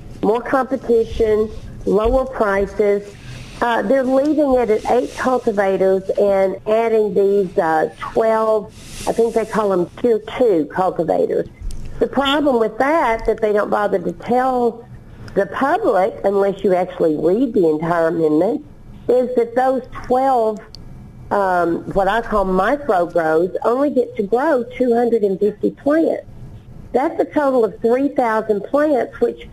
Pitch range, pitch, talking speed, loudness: 200-250 Hz, 225 Hz, 135 wpm, -17 LUFS